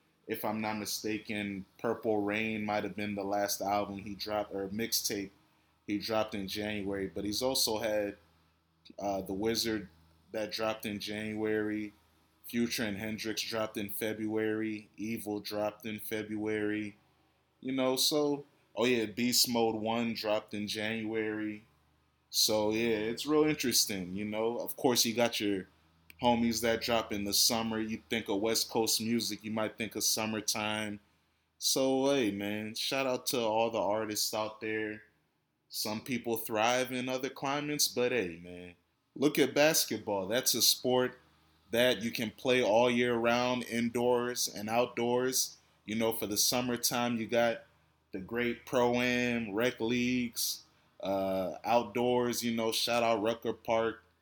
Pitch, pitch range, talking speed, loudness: 110 Hz, 105-120 Hz, 155 wpm, -32 LUFS